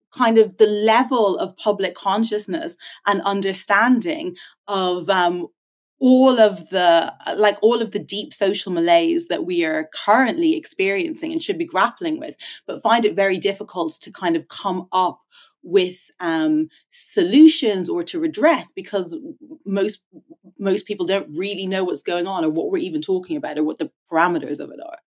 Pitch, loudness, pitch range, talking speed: 220 Hz, -20 LUFS, 195-320 Hz, 165 wpm